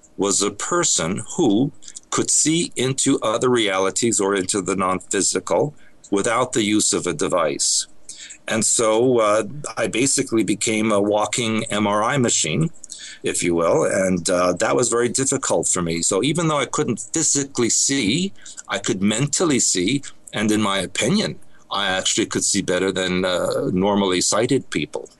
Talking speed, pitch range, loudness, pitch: 155 wpm, 95-125 Hz, -19 LUFS, 105 Hz